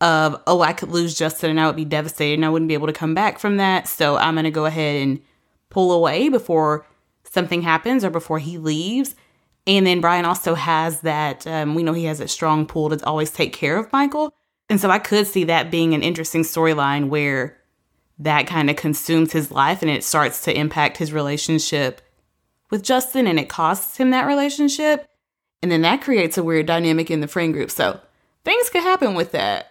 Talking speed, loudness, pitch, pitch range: 215 wpm, -19 LUFS, 160 Hz, 155-185 Hz